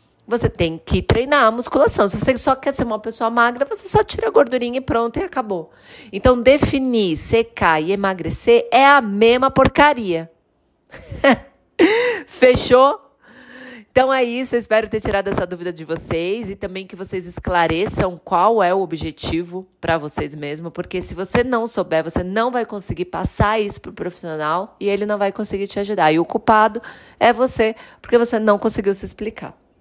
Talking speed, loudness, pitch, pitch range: 175 wpm, -18 LUFS, 215 Hz, 180-250 Hz